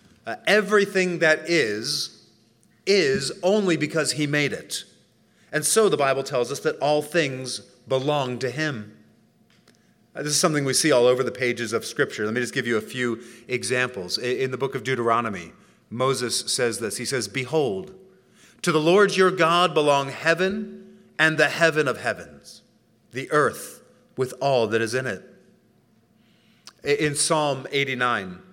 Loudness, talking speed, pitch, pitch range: -23 LUFS, 165 wpm, 140 Hz, 125-165 Hz